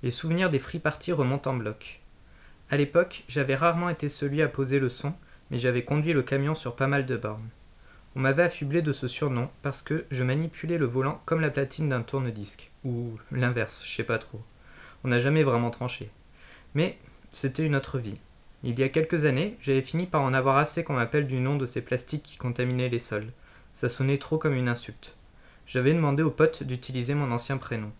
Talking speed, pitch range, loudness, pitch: 210 wpm, 120-150 Hz, -28 LUFS, 135 Hz